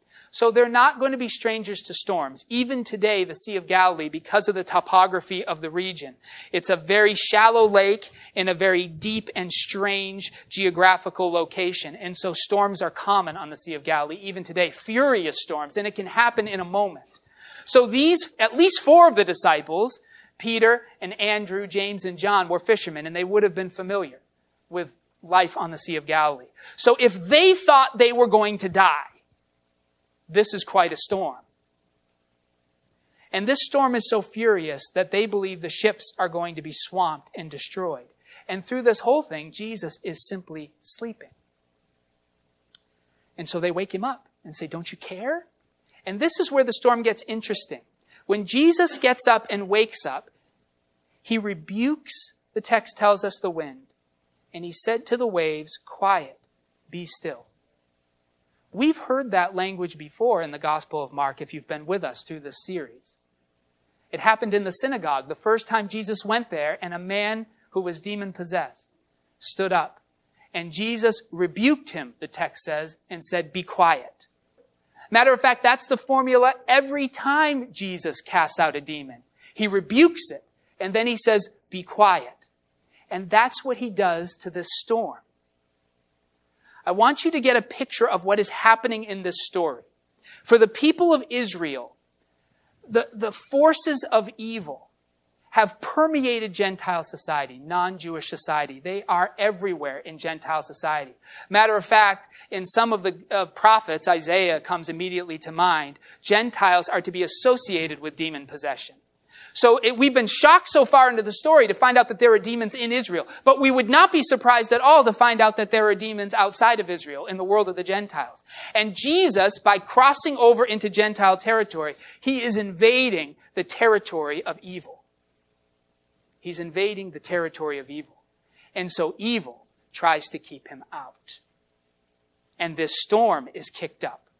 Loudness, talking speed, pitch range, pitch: -21 LUFS, 170 wpm, 160-230 Hz, 195 Hz